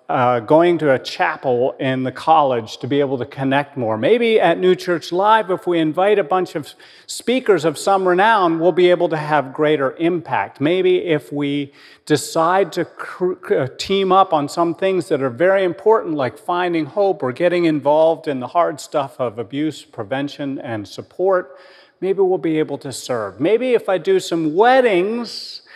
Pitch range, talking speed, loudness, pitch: 145-185 Hz, 185 wpm, -18 LUFS, 170 Hz